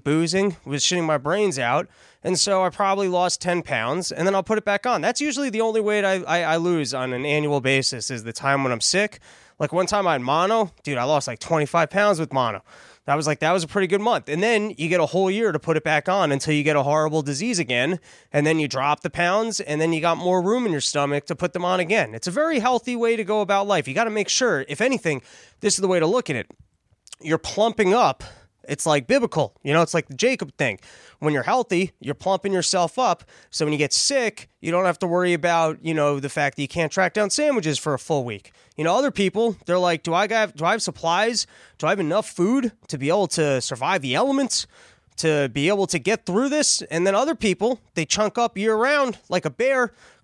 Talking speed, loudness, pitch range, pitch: 250 wpm, -22 LUFS, 150-205 Hz, 175 Hz